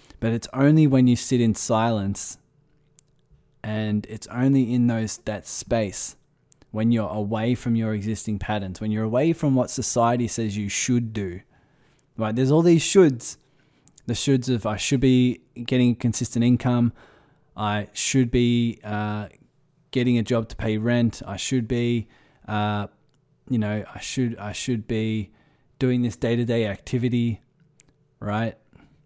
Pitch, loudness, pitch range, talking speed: 120 Hz, -23 LUFS, 110-130 Hz, 155 wpm